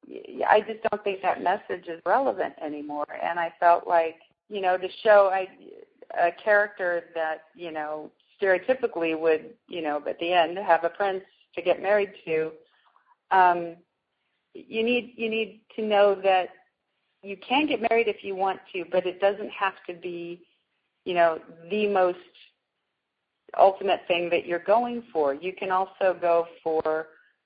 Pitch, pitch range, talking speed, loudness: 185 Hz, 170-210 Hz, 160 wpm, -25 LUFS